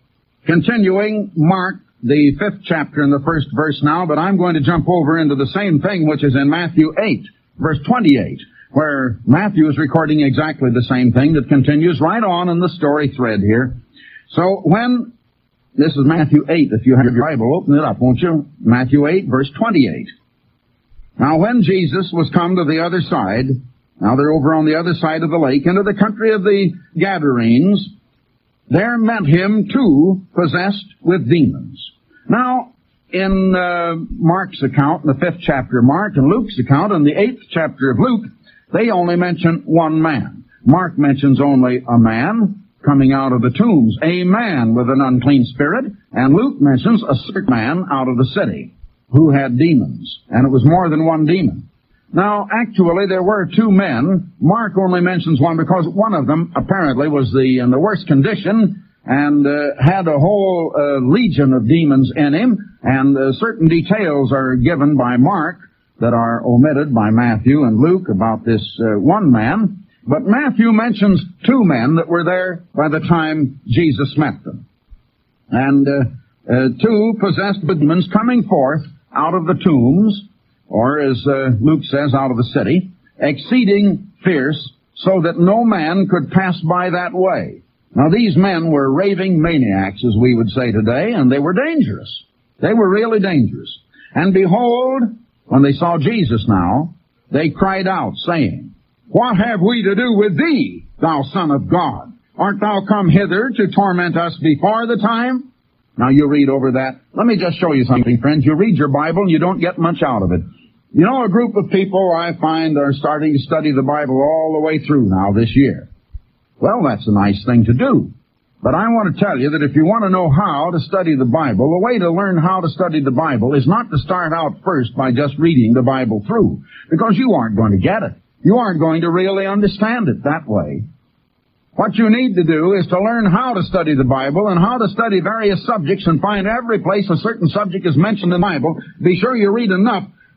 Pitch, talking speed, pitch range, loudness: 165 Hz, 190 wpm, 140-195 Hz, -15 LUFS